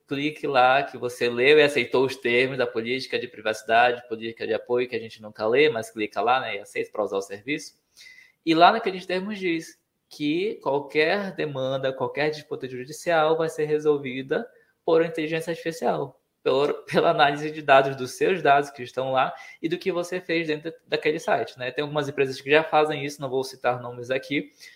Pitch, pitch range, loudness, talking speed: 150 Hz, 130-165 Hz, -24 LUFS, 190 wpm